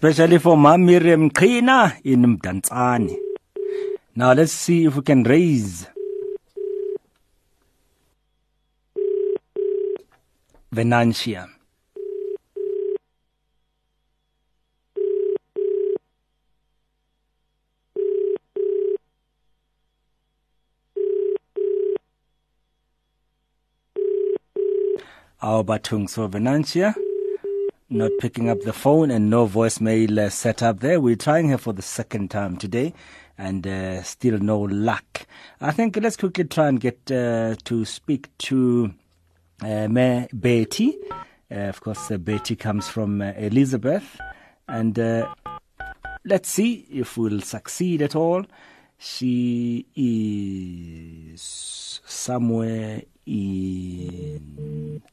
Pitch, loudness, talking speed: 125 Hz, -21 LUFS, 85 wpm